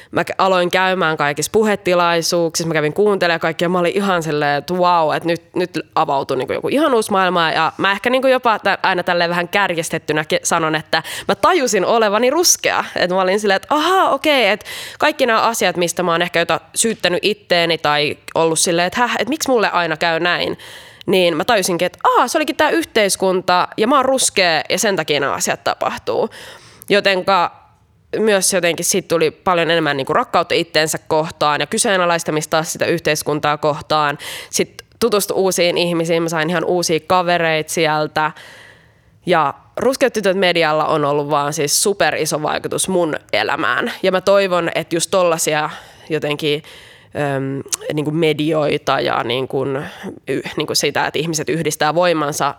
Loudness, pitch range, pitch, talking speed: -16 LUFS, 155-190 Hz, 175 Hz, 165 wpm